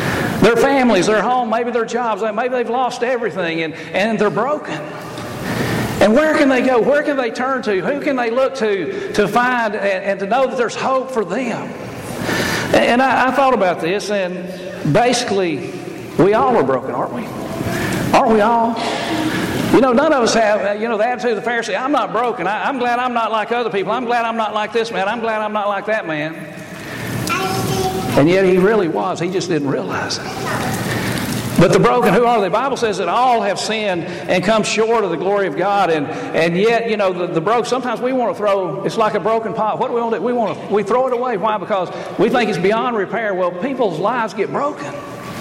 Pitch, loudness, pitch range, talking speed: 220 Hz, -17 LUFS, 195-240 Hz, 225 wpm